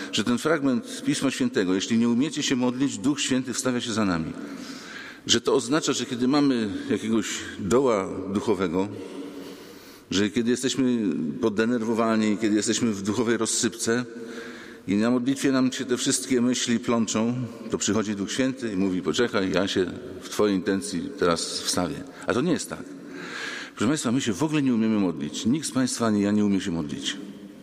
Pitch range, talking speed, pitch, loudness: 105-130 Hz, 175 wpm, 115 Hz, -25 LUFS